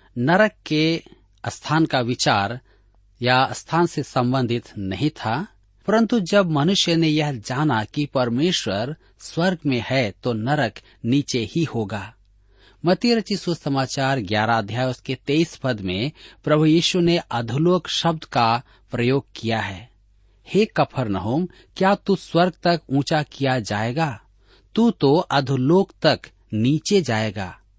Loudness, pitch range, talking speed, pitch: -21 LUFS, 115-165 Hz, 130 wpm, 135 Hz